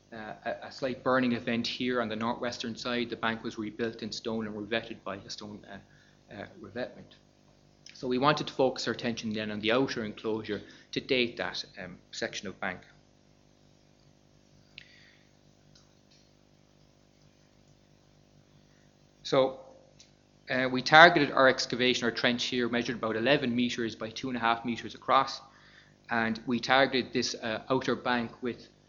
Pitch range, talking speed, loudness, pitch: 115-130 Hz, 150 wpm, -29 LUFS, 120 Hz